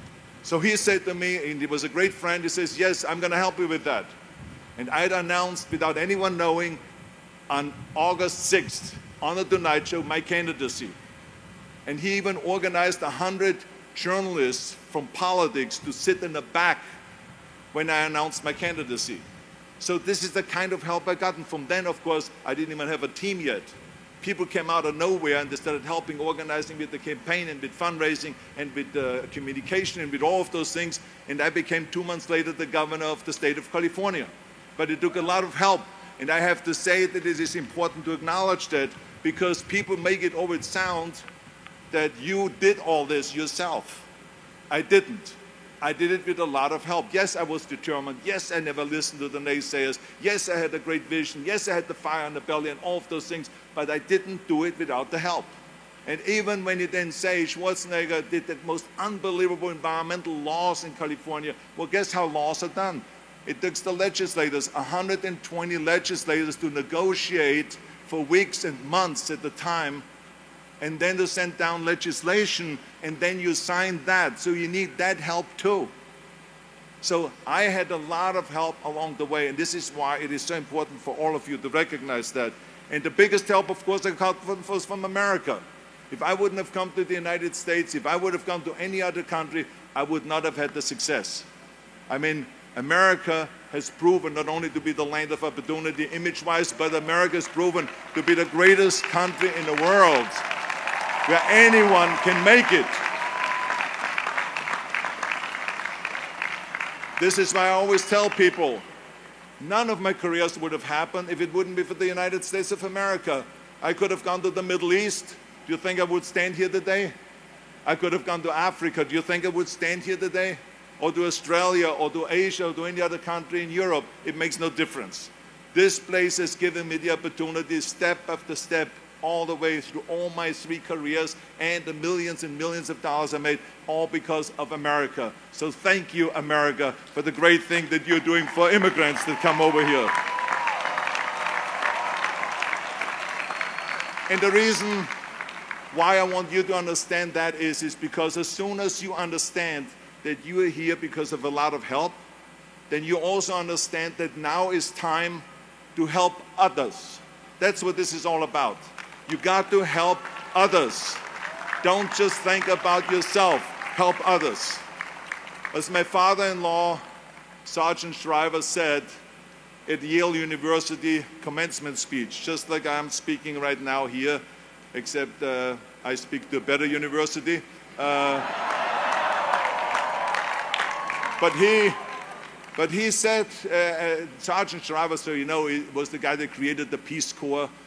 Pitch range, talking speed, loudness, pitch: 155-185 Hz, 180 wpm, -25 LUFS, 170 Hz